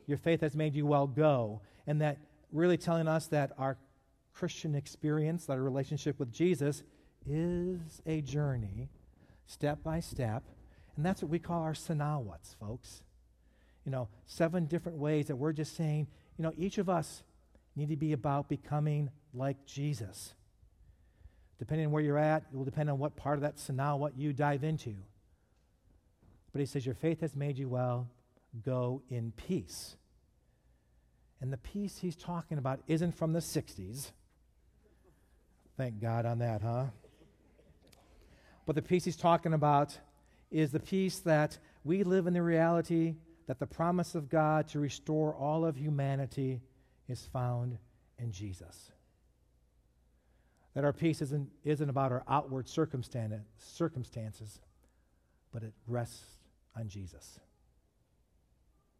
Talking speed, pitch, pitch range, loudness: 145 wpm, 140 Hz, 115-155 Hz, -35 LUFS